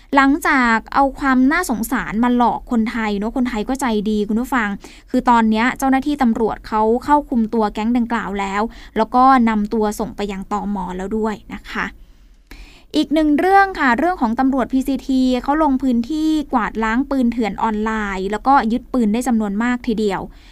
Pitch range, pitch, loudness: 220-265 Hz, 235 Hz, -18 LUFS